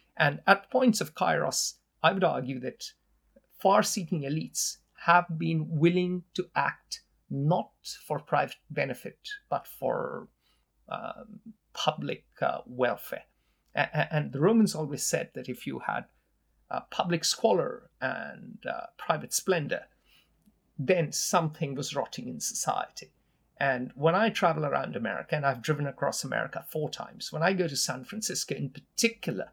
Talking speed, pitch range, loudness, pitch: 145 wpm, 155-210 Hz, -29 LUFS, 175 Hz